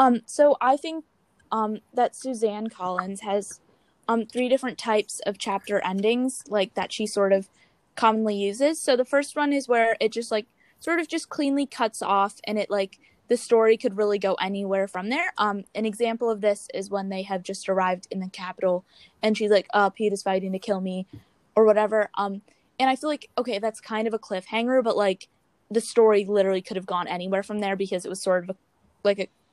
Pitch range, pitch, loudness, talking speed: 195-235 Hz, 210 Hz, -25 LUFS, 215 wpm